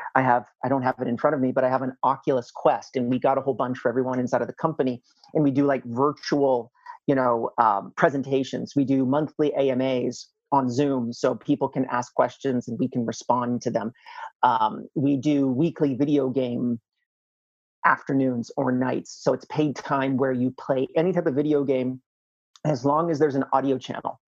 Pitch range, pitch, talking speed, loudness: 125-145 Hz, 135 Hz, 205 wpm, -24 LUFS